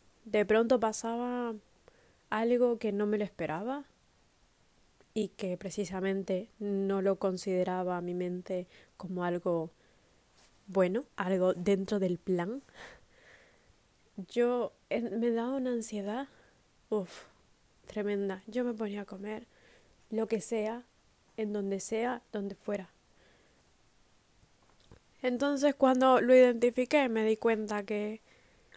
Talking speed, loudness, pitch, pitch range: 110 wpm, -32 LUFS, 210 Hz, 190-235 Hz